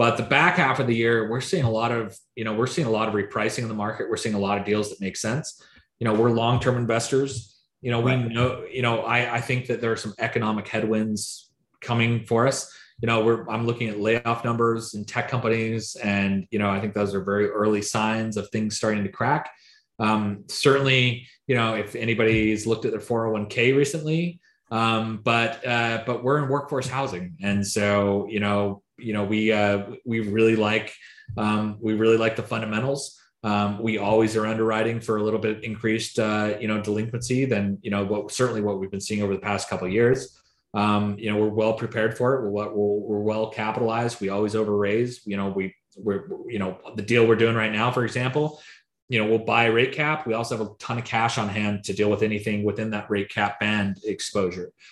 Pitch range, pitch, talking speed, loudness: 105-120 Hz, 110 Hz, 220 wpm, -24 LUFS